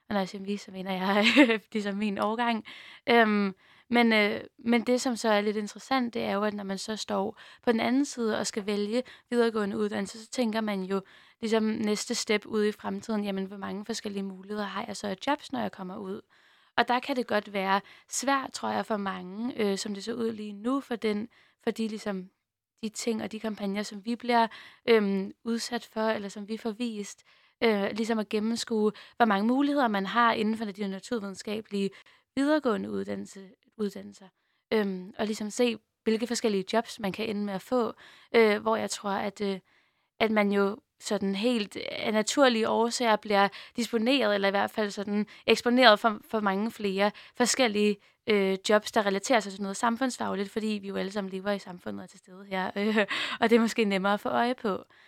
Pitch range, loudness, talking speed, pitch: 200-230 Hz, -28 LUFS, 205 wpm, 215 Hz